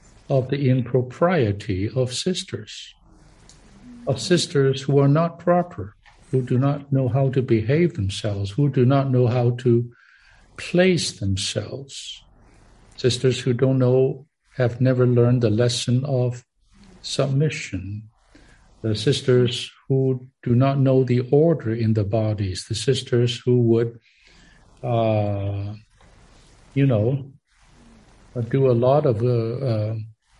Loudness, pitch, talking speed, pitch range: -21 LUFS, 125 Hz, 120 wpm, 110-135 Hz